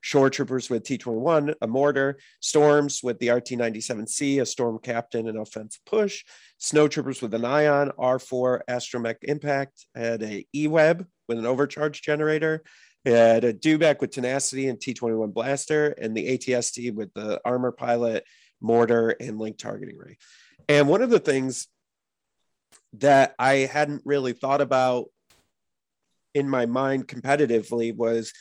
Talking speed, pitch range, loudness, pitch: 145 wpm, 115-145 Hz, -24 LUFS, 130 Hz